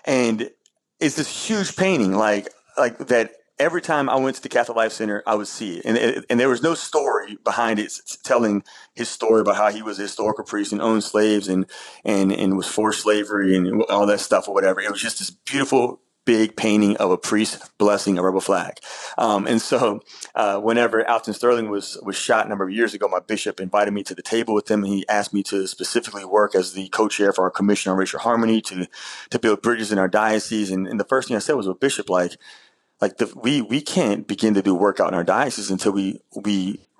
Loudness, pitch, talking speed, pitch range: -21 LUFS, 105 Hz, 230 wpm, 100-110 Hz